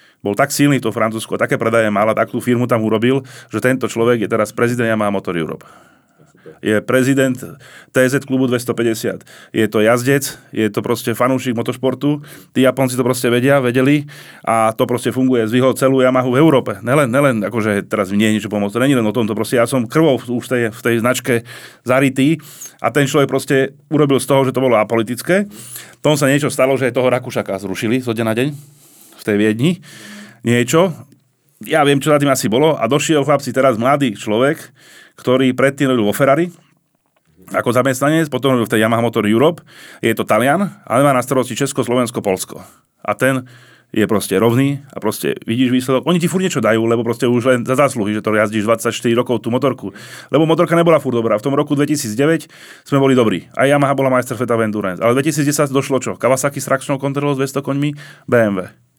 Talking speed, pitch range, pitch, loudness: 200 wpm, 115-140 Hz, 125 Hz, -16 LUFS